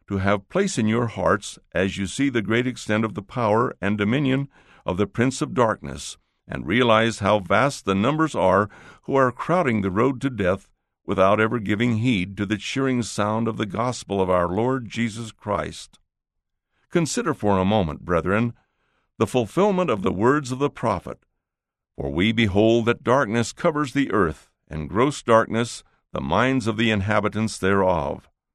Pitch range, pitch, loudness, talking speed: 100-125 Hz, 110 Hz, -22 LUFS, 170 wpm